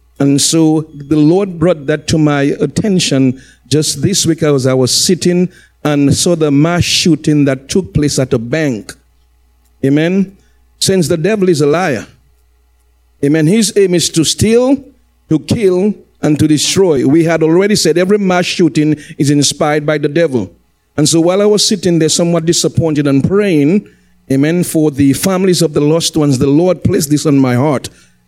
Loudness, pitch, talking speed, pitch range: -11 LUFS, 155 Hz, 175 wpm, 140-175 Hz